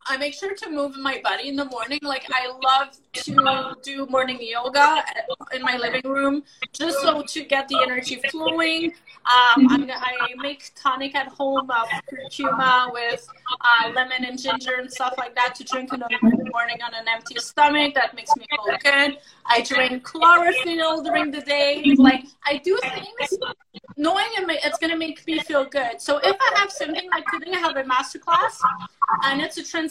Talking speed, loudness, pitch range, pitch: 185 wpm, -21 LUFS, 255-315 Hz, 275 Hz